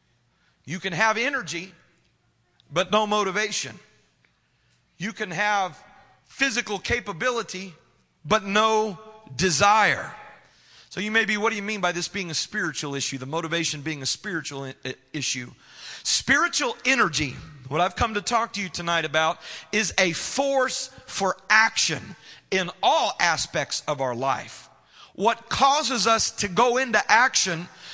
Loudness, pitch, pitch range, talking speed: -23 LUFS, 190 Hz, 165-220 Hz, 140 wpm